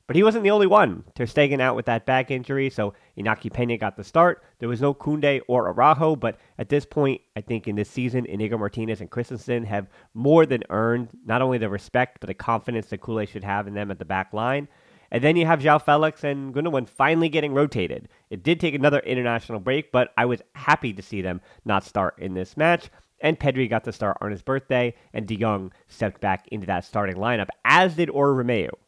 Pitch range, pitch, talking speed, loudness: 110-145 Hz, 120 Hz, 225 wpm, -23 LUFS